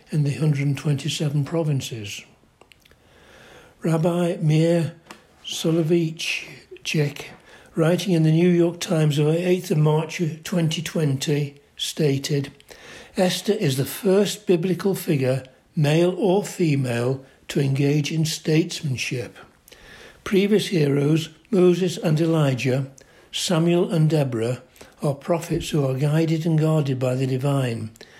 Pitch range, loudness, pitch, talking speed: 140-175 Hz, -22 LUFS, 160 Hz, 110 wpm